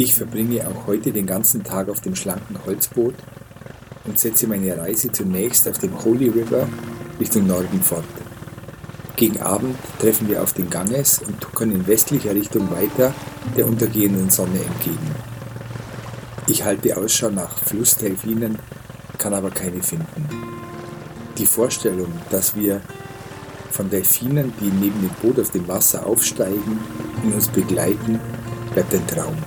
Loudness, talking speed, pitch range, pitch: -19 LUFS, 140 wpm, 105-130 Hz, 115 Hz